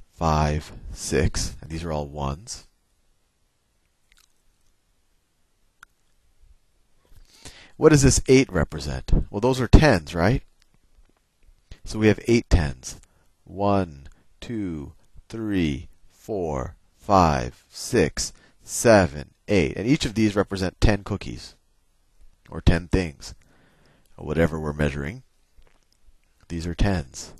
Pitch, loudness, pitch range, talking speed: 85 Hz, -23 LUFS, 75-100 Hz, 105 wpm